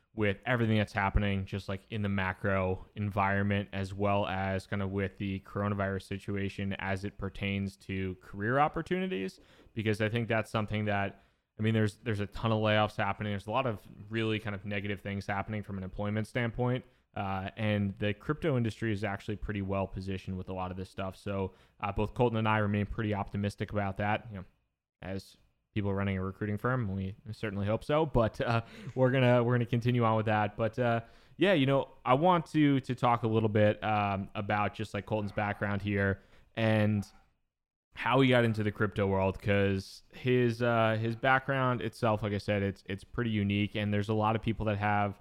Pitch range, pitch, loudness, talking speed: 100-115 Hz, 105 Hz, -32 LUFS, 200 wpm